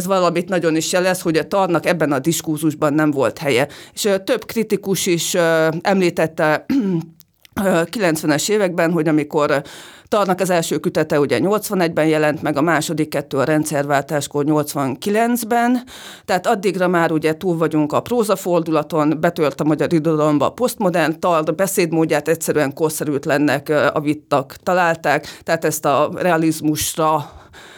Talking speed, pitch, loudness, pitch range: 135 wpm, 165 Hz, -18 LUFS, 155-185 Hz